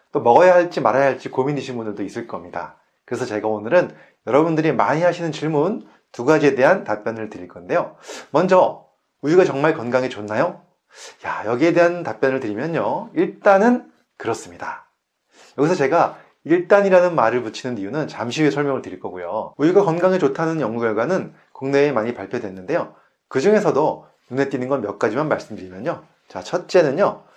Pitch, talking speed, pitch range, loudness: 140 Hz, 375 characters per minute, 115-165 Hz, -19 LUFS